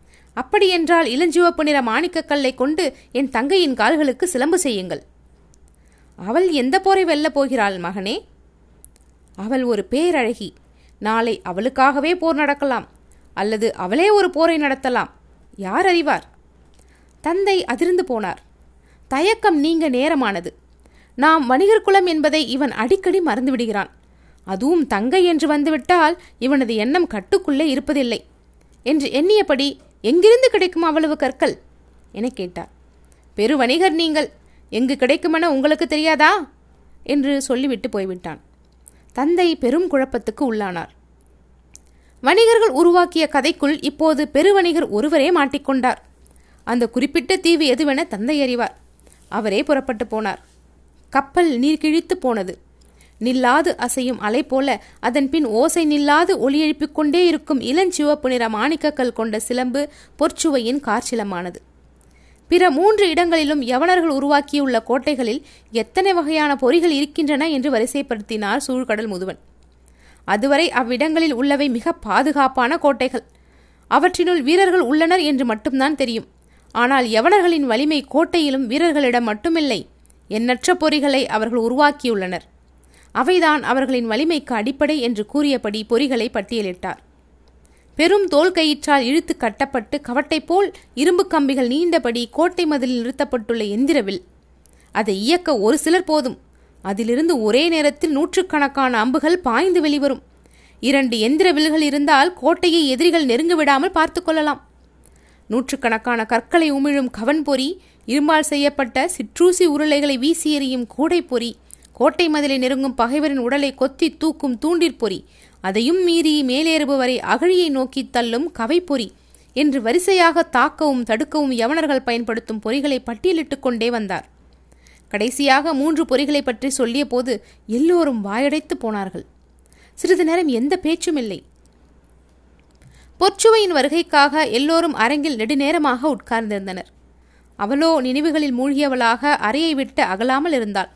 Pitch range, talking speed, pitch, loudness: 235-320 Hz, 105 wpm, 275 Hz, -18 LUFS